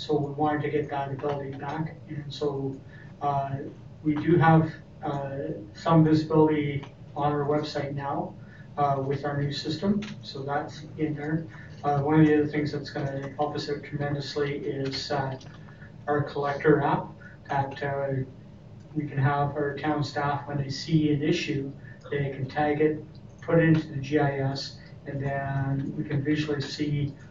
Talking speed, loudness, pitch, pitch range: 165 wpm, -27 LUFS, 145 Hz, 140-150 Hz